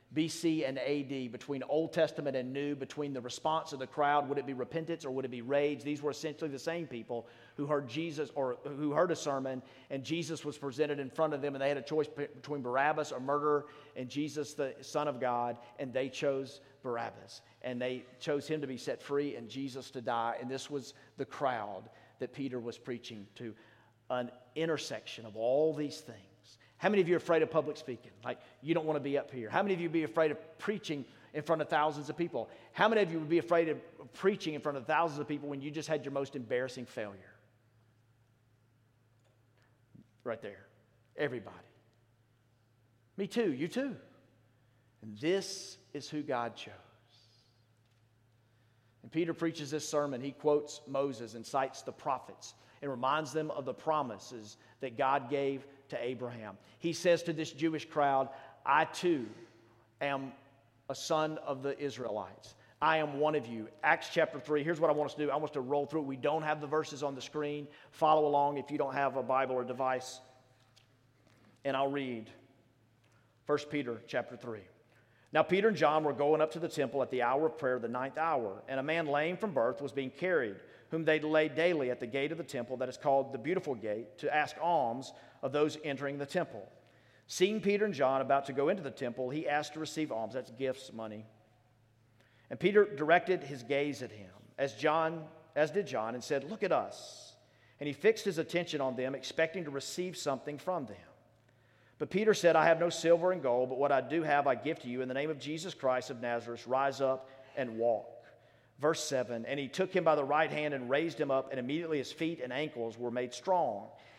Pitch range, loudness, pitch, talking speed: 120-155 Hz, -34 LUFS, 140 Hz, 210 wpm